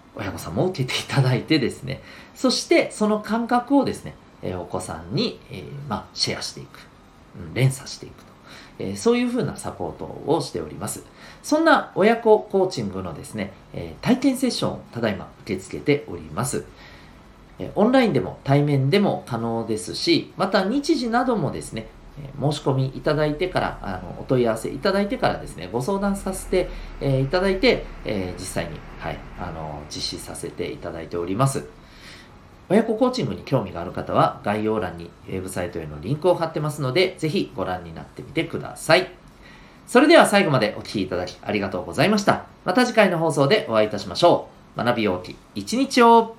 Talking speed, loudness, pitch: 380 characters per minute, -22 LUFS, 145 Hz